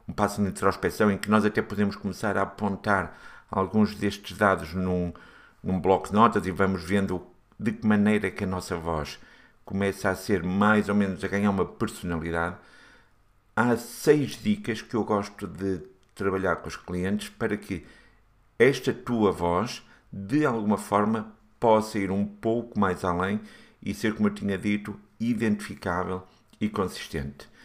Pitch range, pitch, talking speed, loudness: 95-105 Hz, 100 Hz, 165 wpm, -27 LUFS